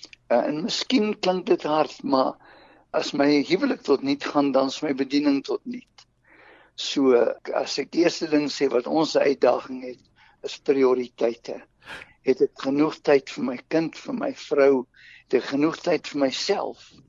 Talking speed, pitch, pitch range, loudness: 165 wpm, 145 Hz, 135-220 Hz, -23 LUFS